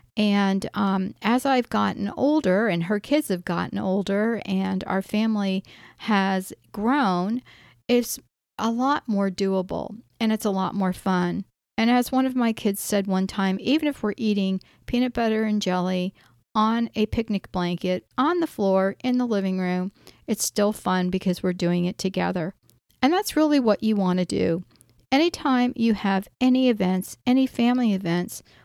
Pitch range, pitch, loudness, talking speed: 190-235 Hz, 205 Hz, -24 LUFS, 170 wpm